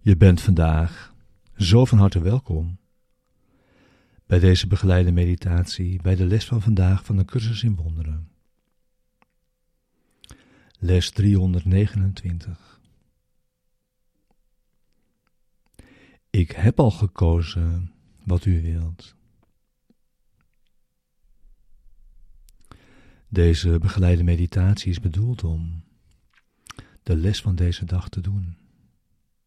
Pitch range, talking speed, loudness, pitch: 85-100 Hz, 90 wpm, -21 LUFS, 90 Hz